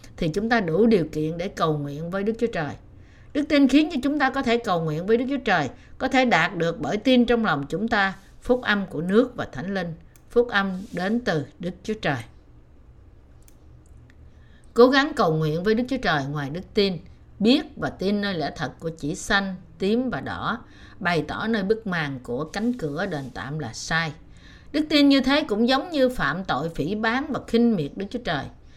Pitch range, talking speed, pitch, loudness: 155-235 Hz, 215 wpm, 195 Hz, -23 LUFS